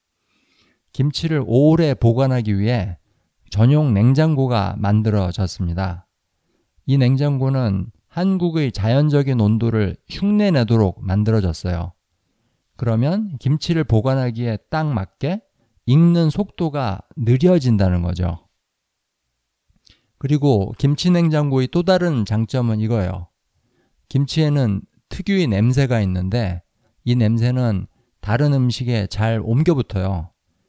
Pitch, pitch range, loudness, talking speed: 120 Hz, 100-145 Hz, -19 LUFS, 240 characters per minute